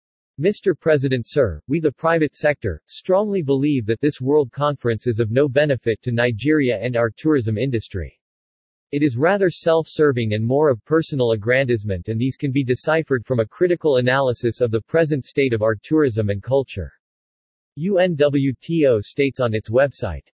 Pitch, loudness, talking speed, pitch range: 135 Hz, -20 LUFS, 165 wpm, 115-150 Hz